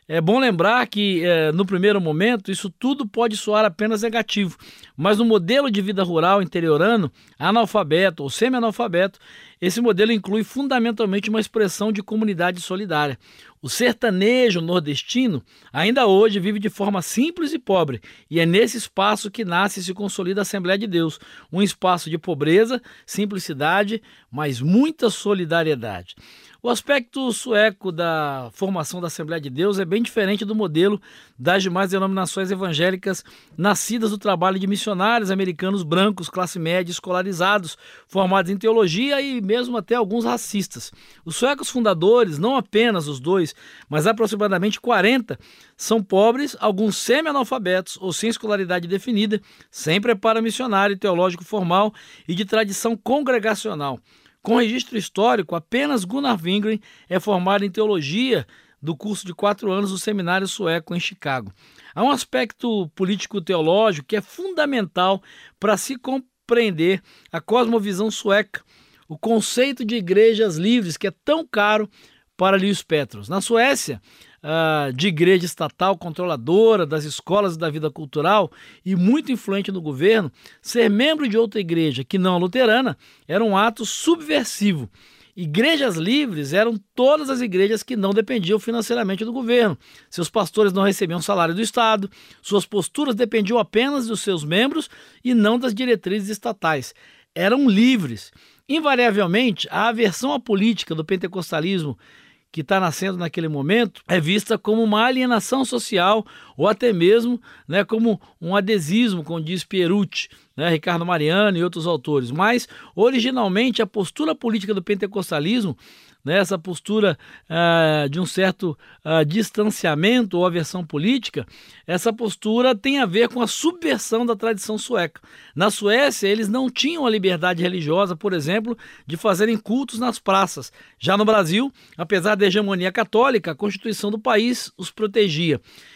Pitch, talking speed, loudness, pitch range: 205 Hz, 145 wpm, -20 LUFS, 180-230 Hz